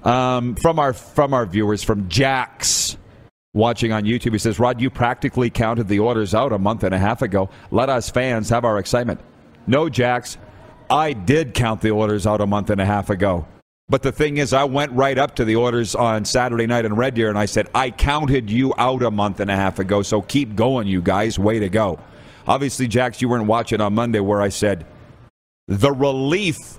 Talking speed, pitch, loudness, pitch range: 215 wpm, 115 Hz, -19 LUFS, 105-125 Hz